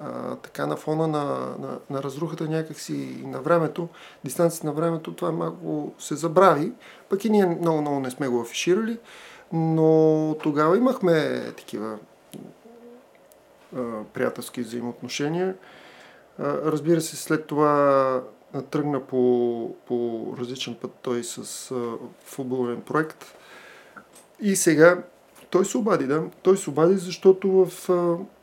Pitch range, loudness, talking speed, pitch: 125-170 Hz, -24 LUFS, 125 wpm, 150 Hz